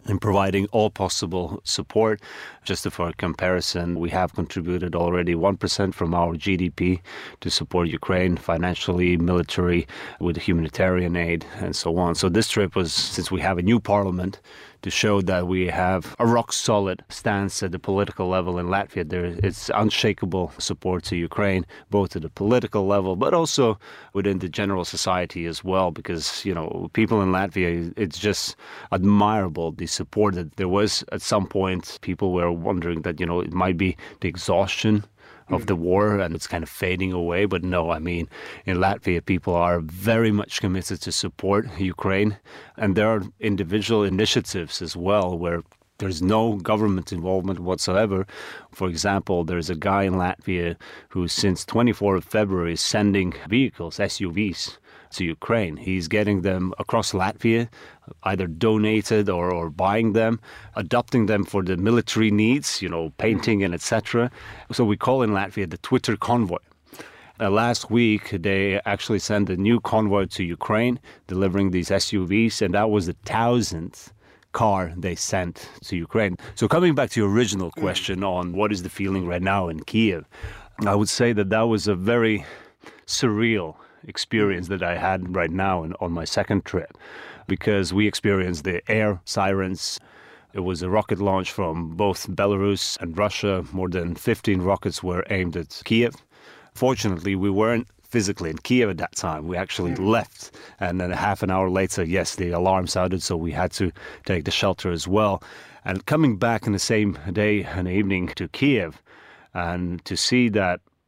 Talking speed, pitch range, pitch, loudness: 170 wpm, 90-105 Hz, 95 Hz, -23 LUFS